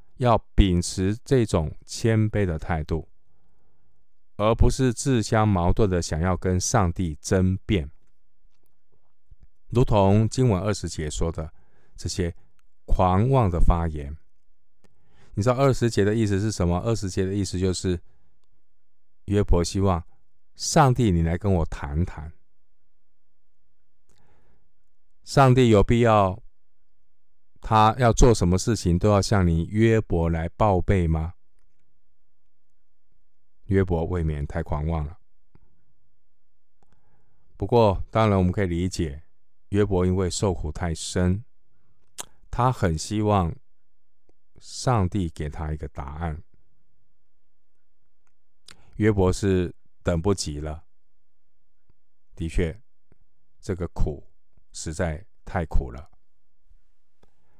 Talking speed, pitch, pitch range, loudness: 155 characters per minute, 90 Hz, 80-105 Hz, -23 LUFS